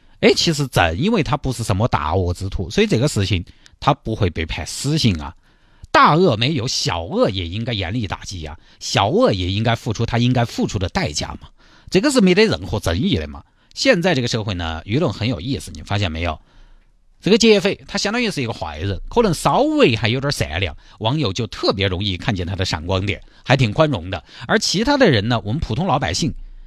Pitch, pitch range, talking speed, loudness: 115 Hz, 95-145 Hz, 320 characters per minute, -19 LUFS